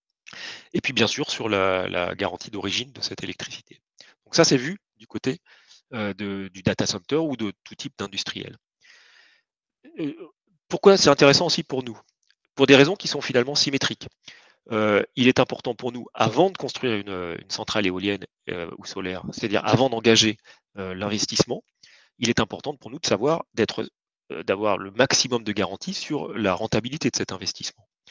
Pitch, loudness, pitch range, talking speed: 125 Hz, -23 LUFS, 105-145 Hz, 175 wpm